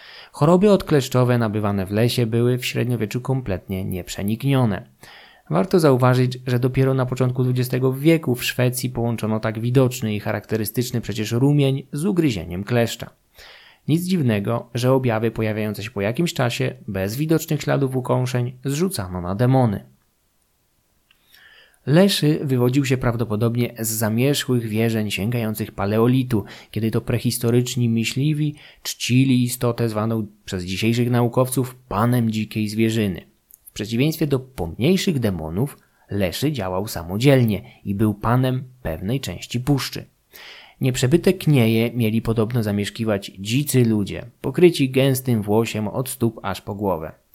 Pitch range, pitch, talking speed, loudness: 110-130 Hz, 120 Hz, 125 wpm, -21 LUFS